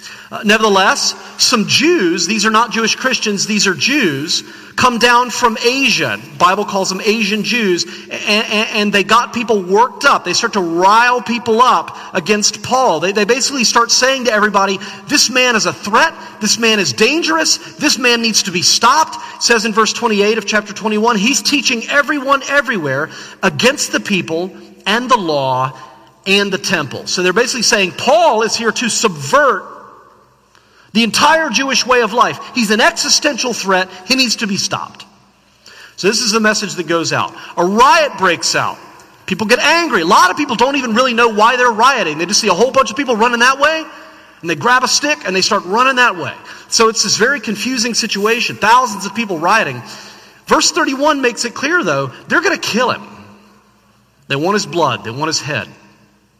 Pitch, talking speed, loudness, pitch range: 225 Hz, 195 wpm, -13 LUFS, 195-250 Hz